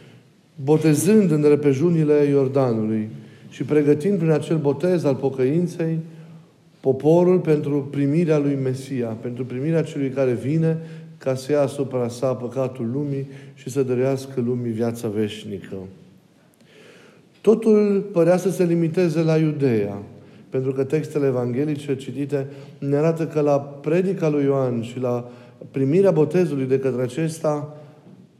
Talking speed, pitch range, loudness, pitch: 125 wpm, 130-160 Hz, -21 LUFS, 145 Hz